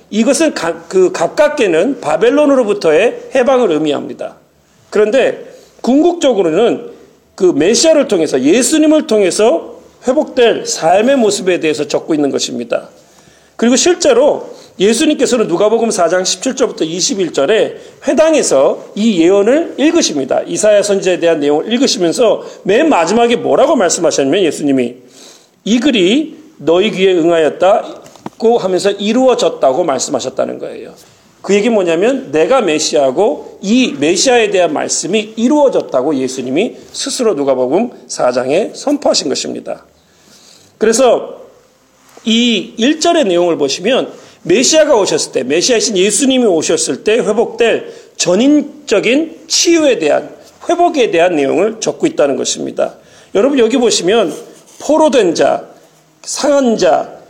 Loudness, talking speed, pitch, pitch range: -12 LUFS, 305 characters per minute, 255 Hz, 205-320 Hz